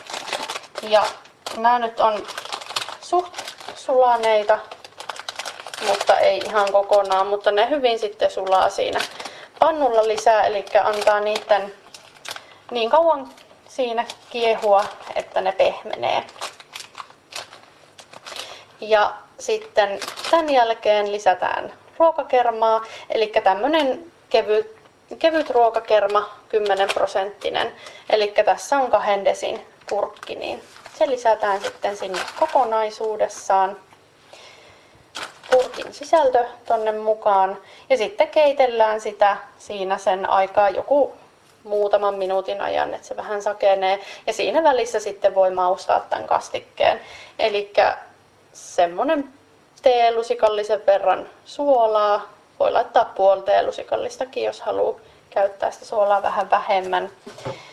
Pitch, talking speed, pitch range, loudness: 215 Hz, 100 wpm, 200-255 Hz, -20 LUFS